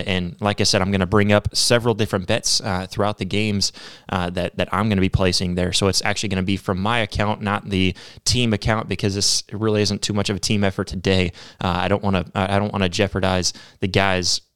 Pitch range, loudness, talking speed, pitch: 95-105 Hz, -20 LUFS, 250 wpm, 100 Hz